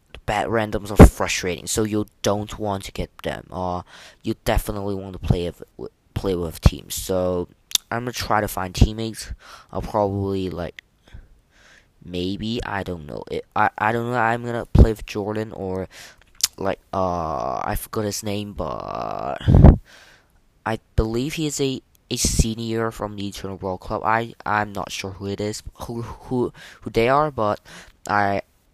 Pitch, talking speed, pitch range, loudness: 105 Hz, 165 wpm, 95-110 Hz, -23 LUFS